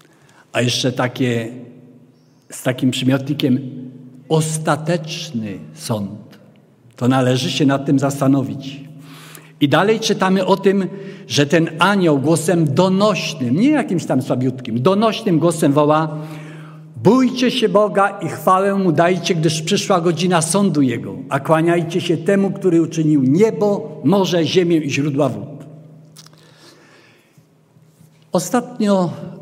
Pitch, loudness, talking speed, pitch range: 155 Hz, -17 LUFS, 115 wpm, 140-185 Hz